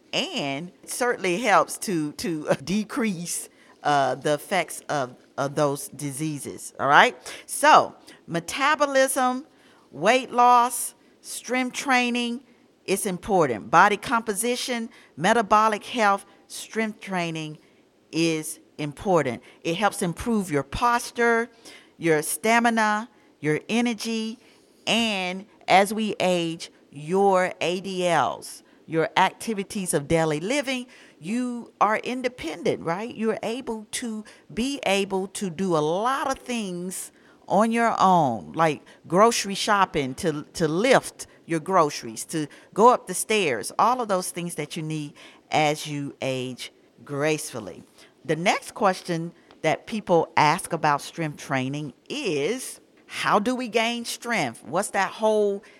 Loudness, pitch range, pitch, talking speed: -24 LUFS, 160-230 Hz, 195 Hz, 120 wpm